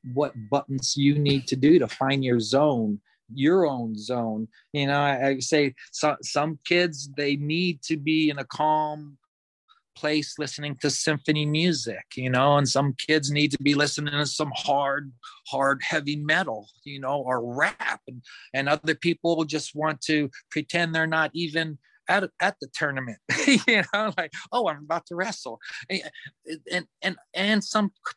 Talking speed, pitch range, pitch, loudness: 175 wpm, 140-160 Hz, 150 Hz, -25 LUFS